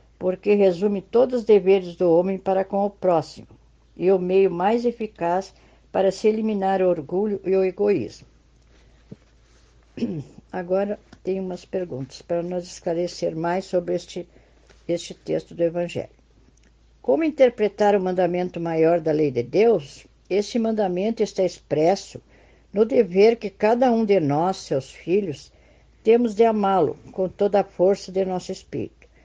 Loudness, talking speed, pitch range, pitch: -22 LUFS, 145 wpm, 175-205 Hz, 190 Hz